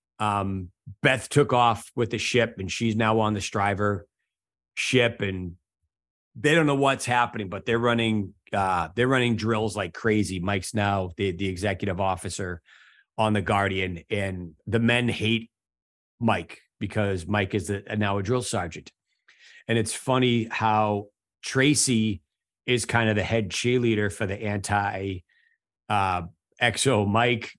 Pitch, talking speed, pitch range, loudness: 105 Hz, 150 wpm, 100-115 Hz, -25 LUFS